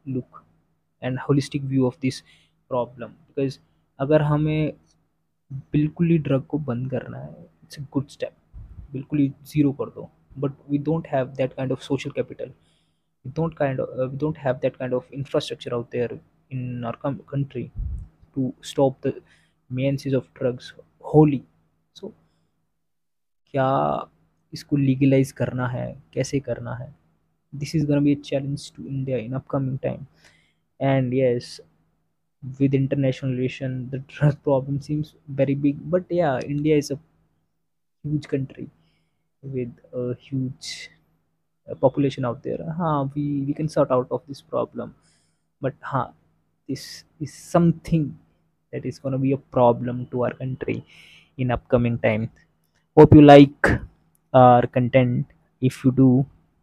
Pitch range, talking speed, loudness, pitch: 125-145 Hz, 130 wpm, -23 LUFS, 135 Hz